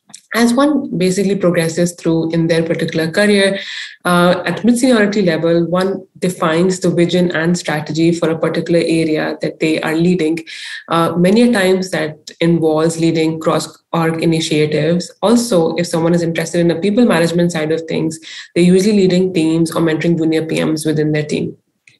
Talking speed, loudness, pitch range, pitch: 165 wpm, -15 LUFS, 160-185 Hz, 170 Hz